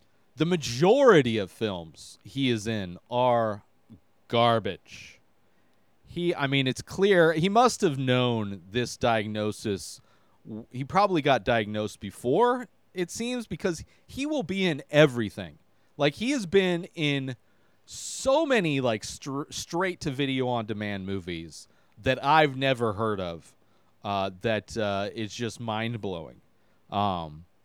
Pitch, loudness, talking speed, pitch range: 120 Hz, -26 LUFS, 130 wpm, 105-155 Hz